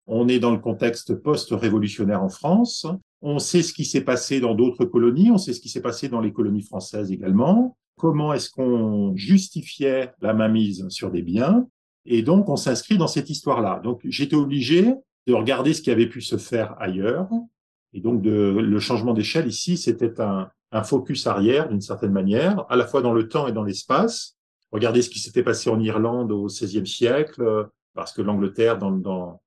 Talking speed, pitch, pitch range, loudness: 195 wpm, 120 Hz, 110-150 Hz, -22 LUFS